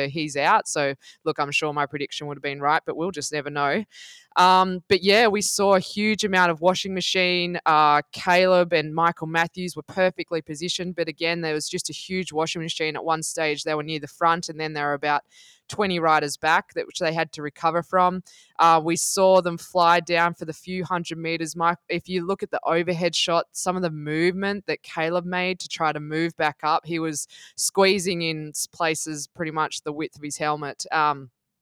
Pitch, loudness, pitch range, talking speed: 165 Hz, -23 LUFS, 155-180 Hz, 215 wpm